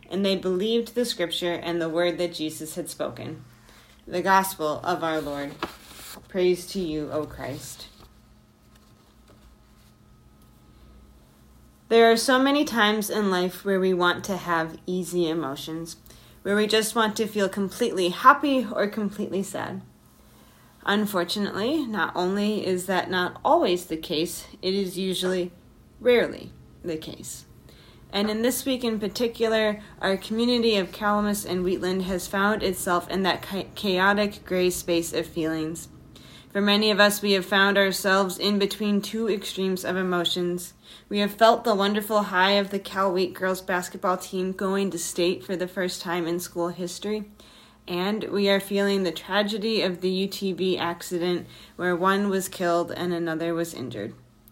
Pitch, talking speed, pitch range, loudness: 185 Hz, 155 wpm, 175-205 Hz, -25 LUFS